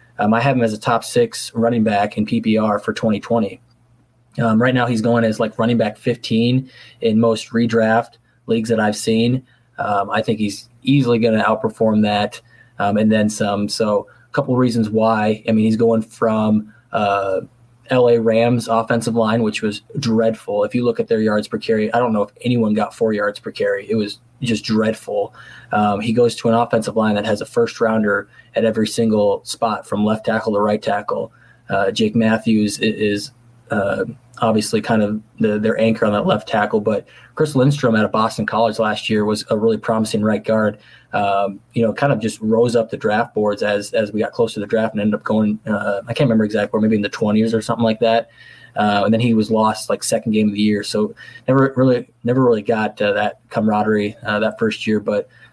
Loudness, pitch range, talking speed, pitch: -18 LUFS, 105-115 Hz, 215 wpm, 110 Hz